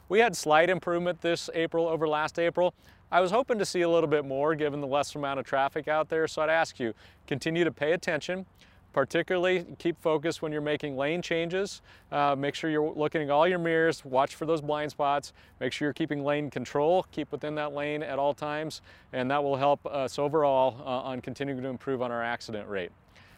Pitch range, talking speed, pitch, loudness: 135-165 Hz, 215 wpm, 150 Hz, -29 LUFS